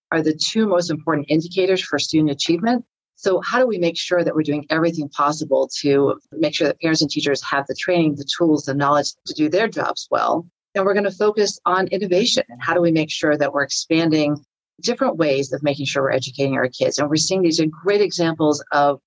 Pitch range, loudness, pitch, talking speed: 145-185 Hz, -19 LUFS, 160 Hz, 225 wpm